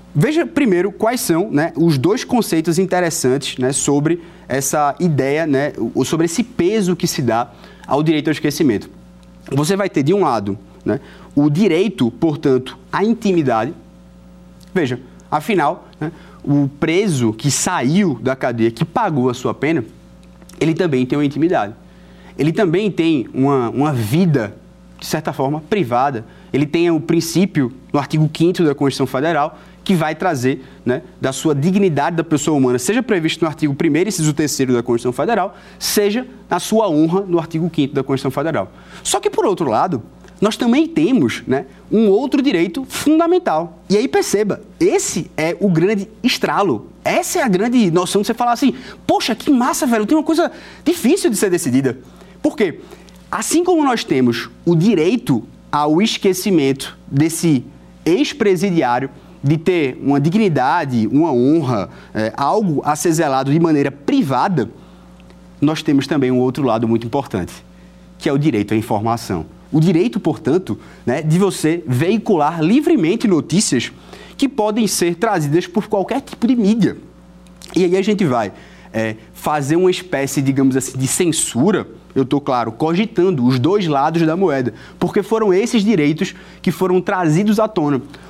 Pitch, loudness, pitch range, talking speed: 165 Hz, -17 LUFS, 135-200 Hz, 160 wpm